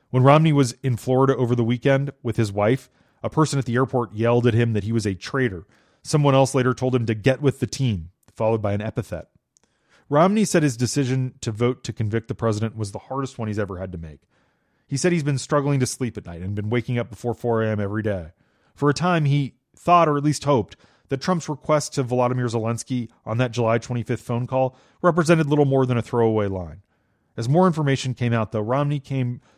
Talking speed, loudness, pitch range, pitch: 225 wpm, -22 LUFS, 110-140 Hz, 125 Hz